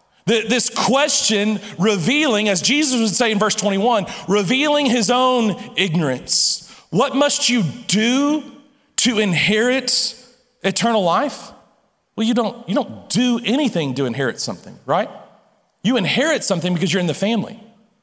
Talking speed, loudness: 135 wpm, -18 LUFS